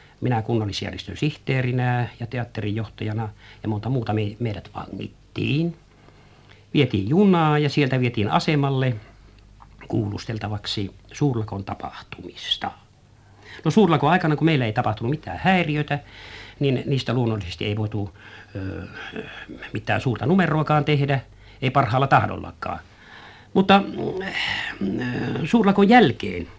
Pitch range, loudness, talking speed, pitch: 105-145 Hz, -22 LUFS, 100 wpm, 115 Hz